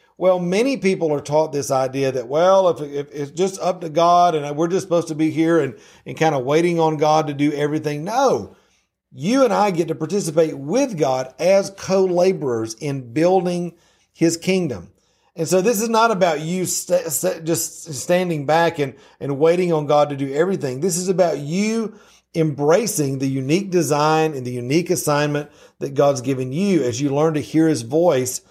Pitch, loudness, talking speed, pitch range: 160 Hz, -19 LUFS, 190 wpm, 145-180 Hz